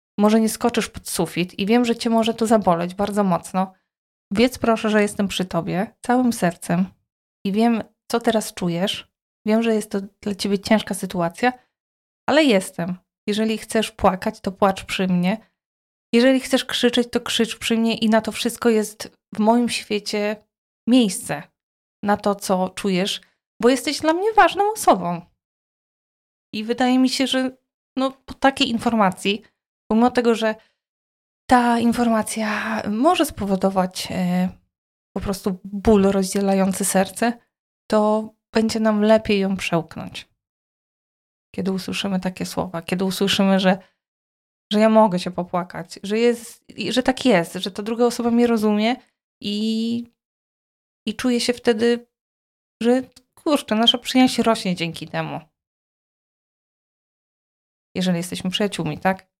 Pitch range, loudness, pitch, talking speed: 195-235 Hz, -21 LUFS, 215 Hz, 135 wpm